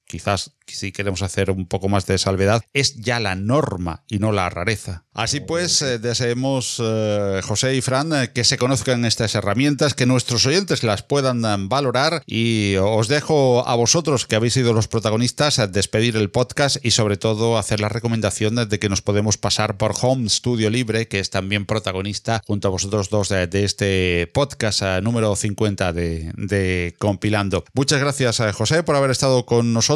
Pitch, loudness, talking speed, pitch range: 110 Hz, -19 LUFS, 175 wpm, 100-125 Hz